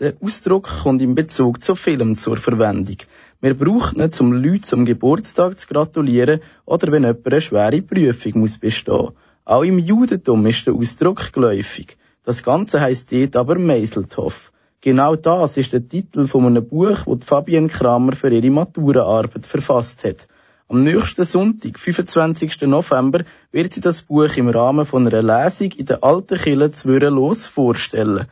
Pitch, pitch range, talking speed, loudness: 140 Hz, 120-165 Hz, 160 wpm, -16 LUFS